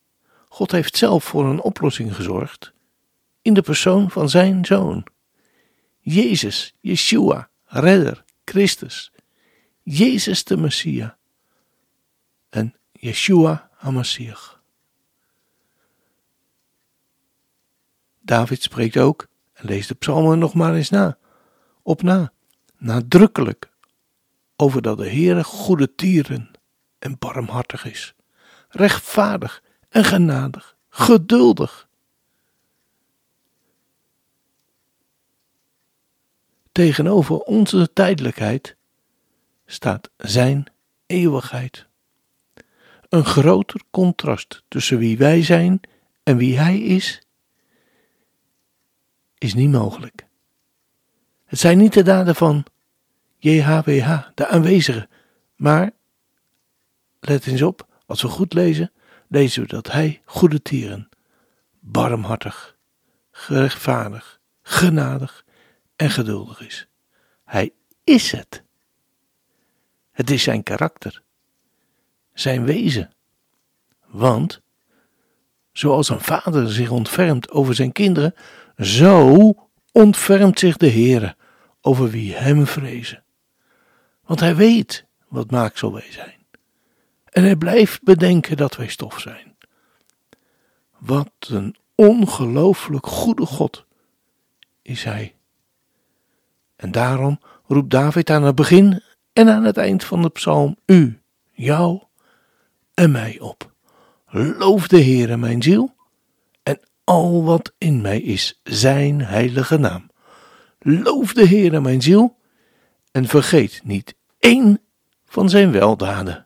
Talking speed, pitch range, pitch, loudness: 100 wpm, 125-185 Hz, 150 Hz, -17 LUFS